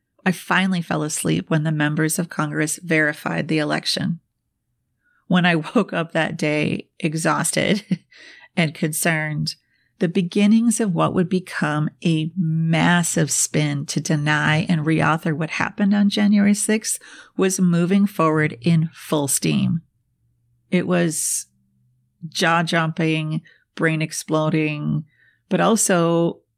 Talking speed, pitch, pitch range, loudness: 120 wpm, 165 Hz, 155-185 Hz, -20 LUFS